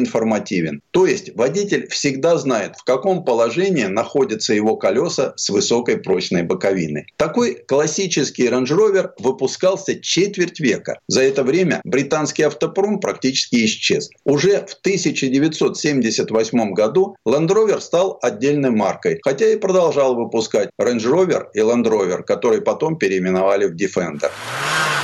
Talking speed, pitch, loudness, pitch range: 125 wpm, 150 Hz, -18 LUFS, 125-195 Hz